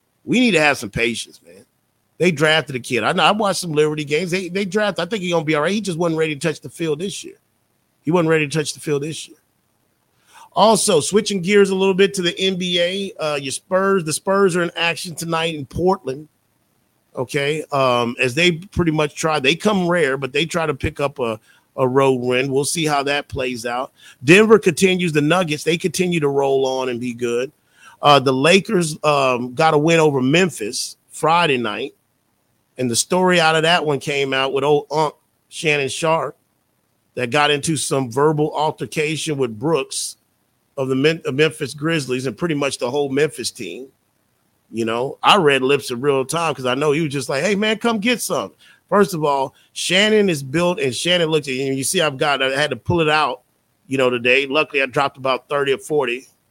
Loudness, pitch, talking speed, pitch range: -18 LUFS, 150 Hz, 215 wpm, 135-175 Hz